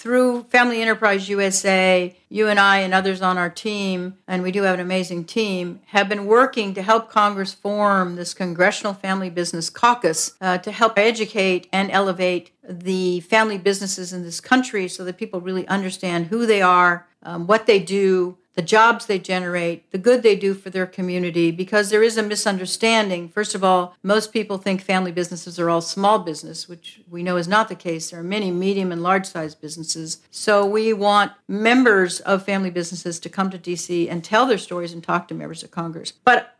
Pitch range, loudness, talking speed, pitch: 180-210 Hz, -20 LUFS, 195 wpm, 190 Hz